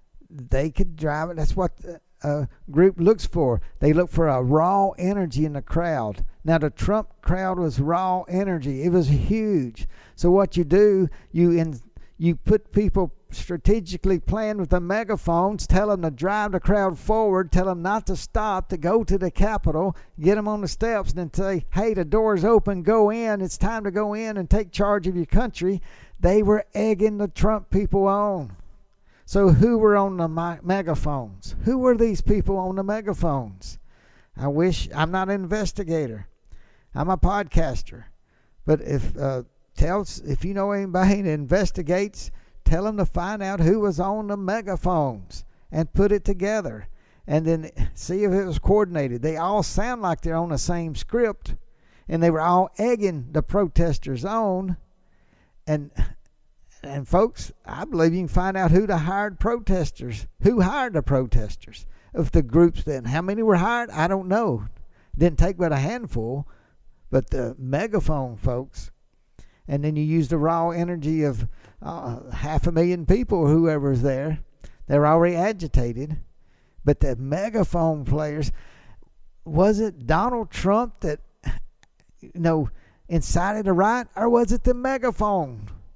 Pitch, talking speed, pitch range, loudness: 175 Hz, 165 wpm, 150-200 Hz, -23 LUFS